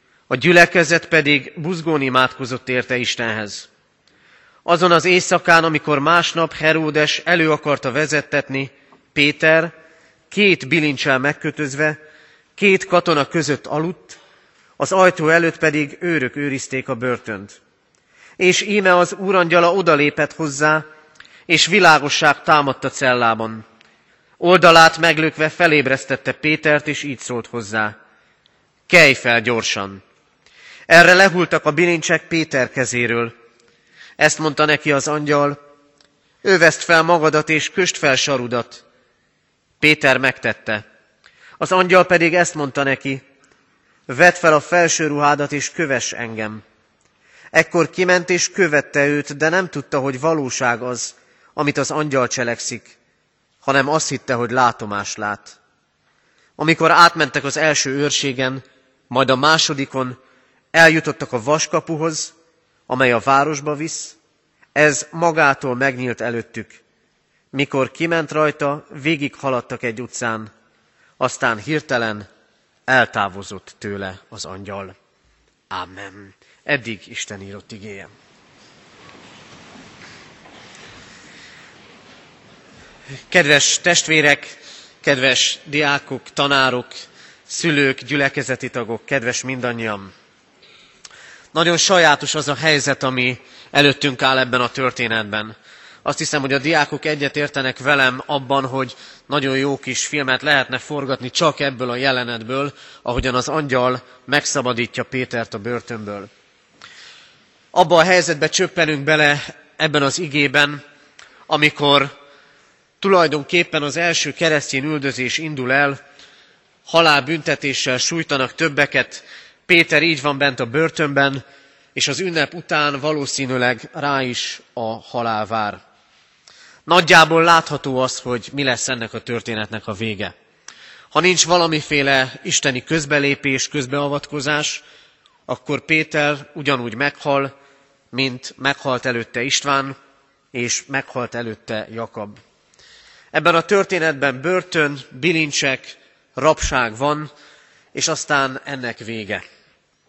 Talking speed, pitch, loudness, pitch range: 105 wpm, 140 Hz, -17 LUFS, 125-155 Hz